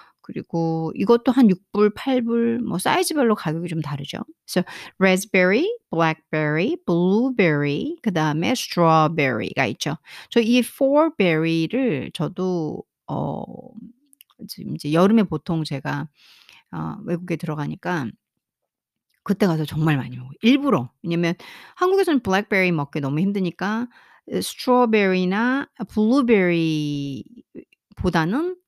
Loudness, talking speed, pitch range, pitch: -21 LUFS, 270 characters per minute, 160-240 Hz, 190 Hz